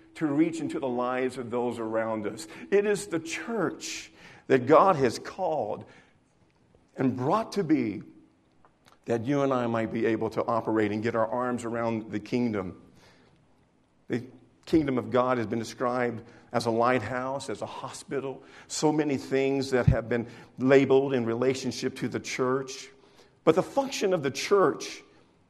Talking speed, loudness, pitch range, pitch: 160 wpm, -28 LUFS, 115-140 Hz, 125 Hz